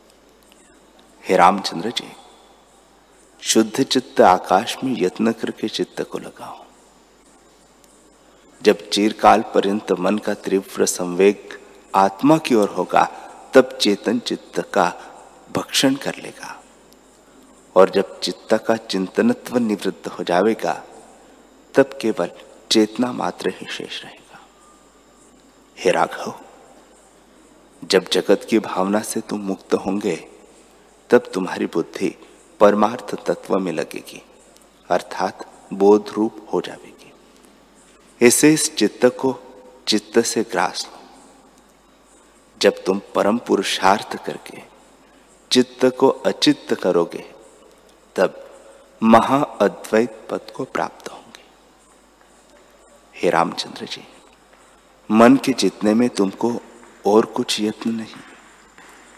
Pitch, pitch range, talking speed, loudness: 110 Hz, 100-125 Hz, 100 wpm, -19 LUFS